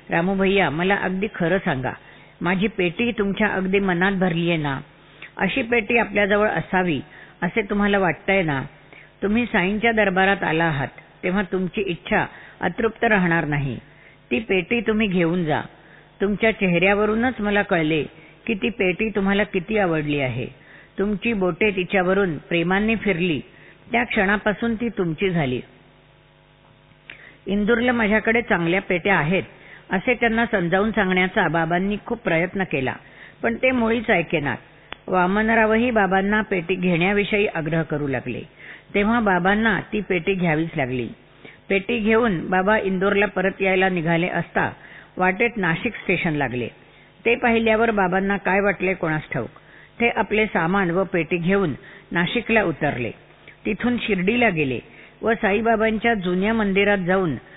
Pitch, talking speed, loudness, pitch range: 195 Hz, 130 wpm, -21 LUFS, 170-215 Hz